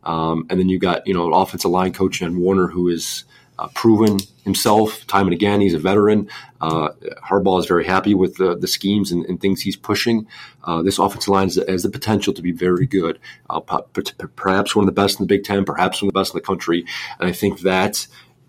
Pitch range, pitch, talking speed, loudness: 90-100 Hz, 95 Hz, 235 wpm, -18 LUFS